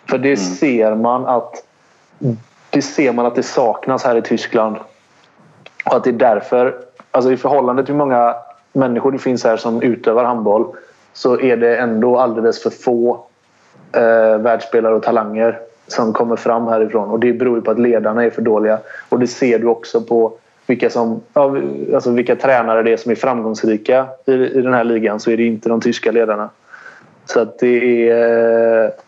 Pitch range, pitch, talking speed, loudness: 115-125 Hz, 115 Hz, 185 wpm, -15 LUFS